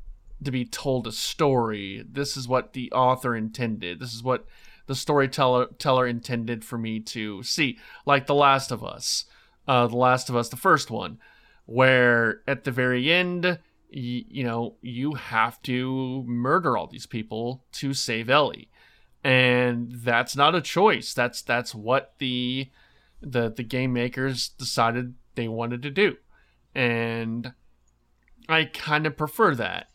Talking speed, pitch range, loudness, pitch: 150 wpm, 115-130 Hz, -24 LUFS, 125 Hz